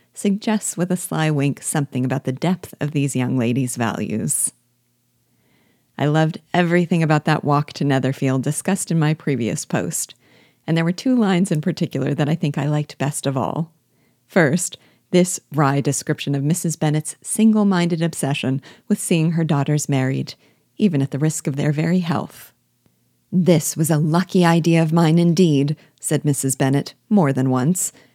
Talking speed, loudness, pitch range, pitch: 170 wpm, -20 LUFS, 140-175 Hz, 155 Hz